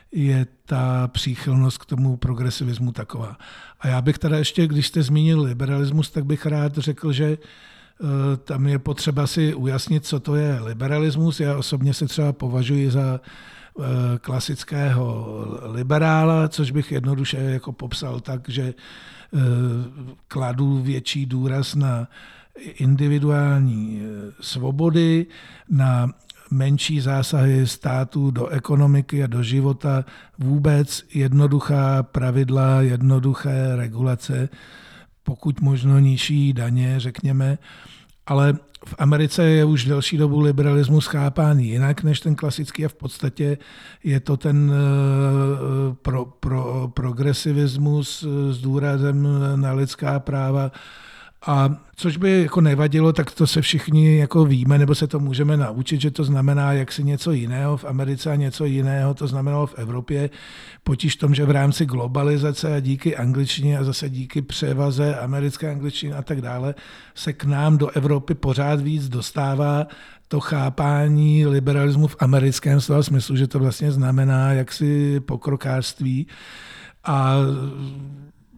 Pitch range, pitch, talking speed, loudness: 135-150 Hz, 140 Hz, 130 wpm, -21 LUFS